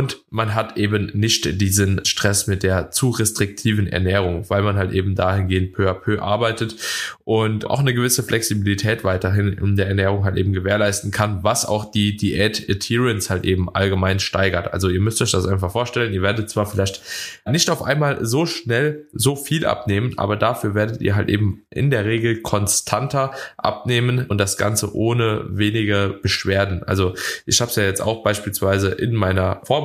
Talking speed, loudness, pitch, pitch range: 175 wpm, -20 LUFS, 105 Hz, 95-115 Hz